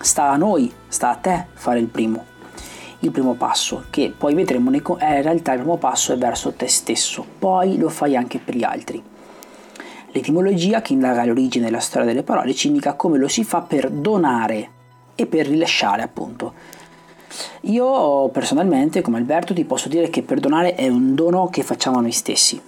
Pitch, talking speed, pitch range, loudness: 165 Hz, 190 wpm, 125-205 Hz, -19 LUFS